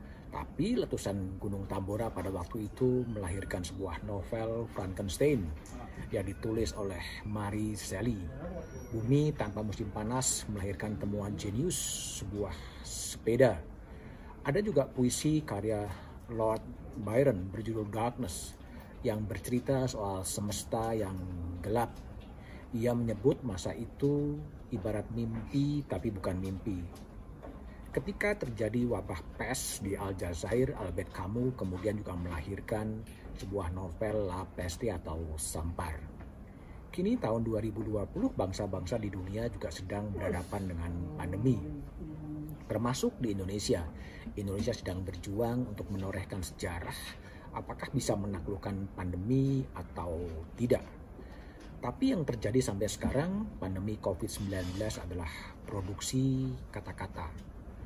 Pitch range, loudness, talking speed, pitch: 95-115 Hz, -35 LUFS, 105 wpm, 105 Hz